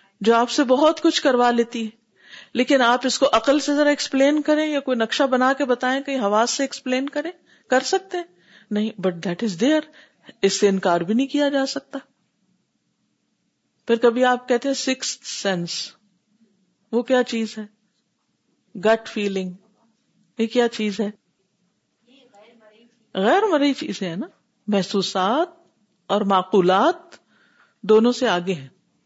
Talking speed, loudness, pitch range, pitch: 150 wpm, -21 LUFS, 205-275 Hz, 235 Hz